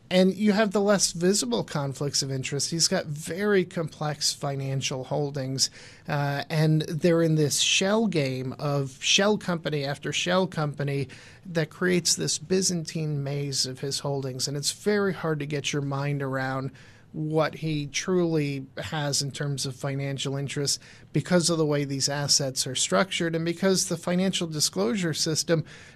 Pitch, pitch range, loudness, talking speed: 150 Hz, 140-170 Hz, -26 LUFS, 155 wpm